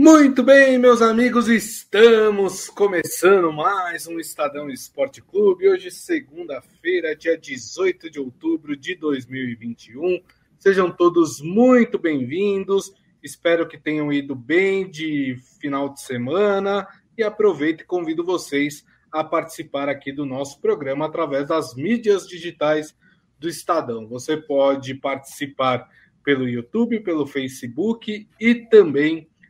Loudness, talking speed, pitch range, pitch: -20 LUFS, 120 wpm, 145-230 Hz, 170 Hz